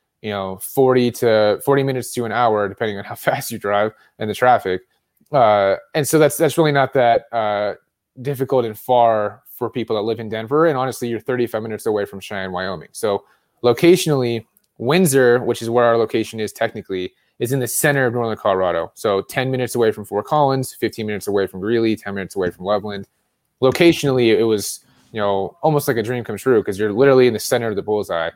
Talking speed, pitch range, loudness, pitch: 210 wpm, 105-130 Hz, -18 LUFS, 115 Hz